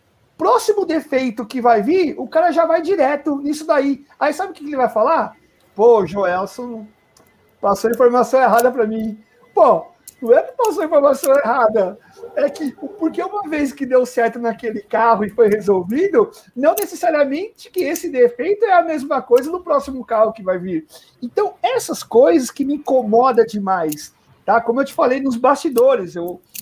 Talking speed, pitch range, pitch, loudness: 170 wpm, 230-335 Hz, 270 Hz, -17 LUFS